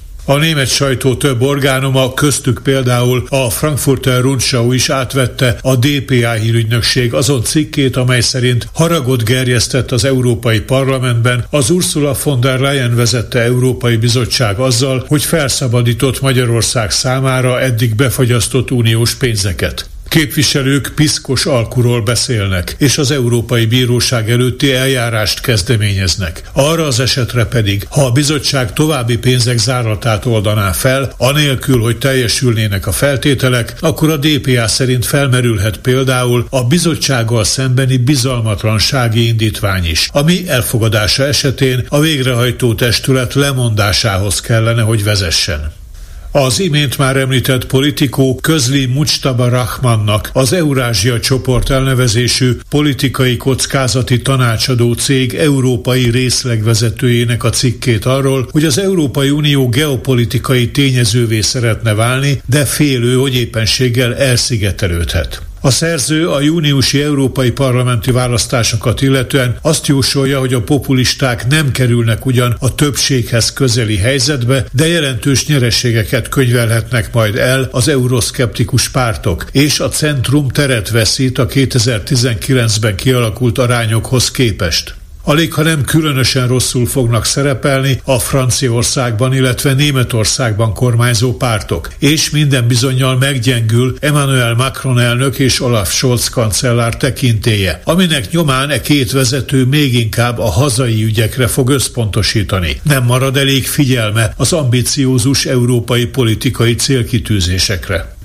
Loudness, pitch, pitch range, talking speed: -12 LUFS, 125 Hz, 115-135 Hz, 115 wpm